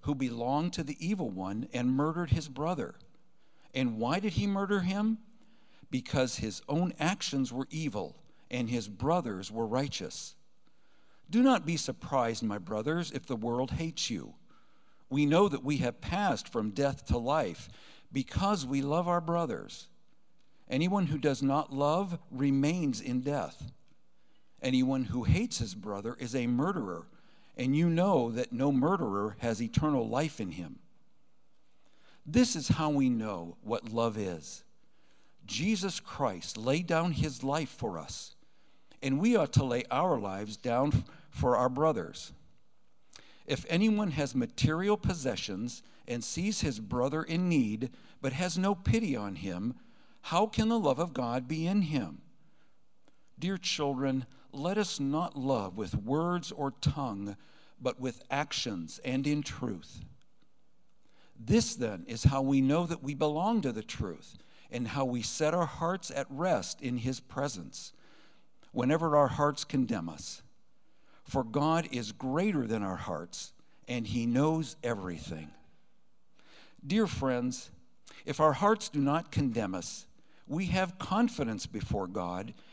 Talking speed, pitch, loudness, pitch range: 145 wpm, 140 Hz, -32 LUFS, 120-170 Hz